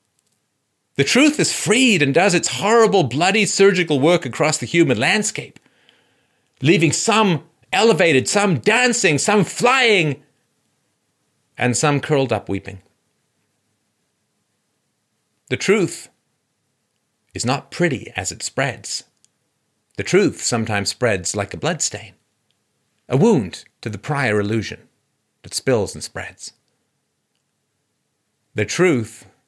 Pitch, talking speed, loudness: 145 Hz, 110 wpm, -17 LUFS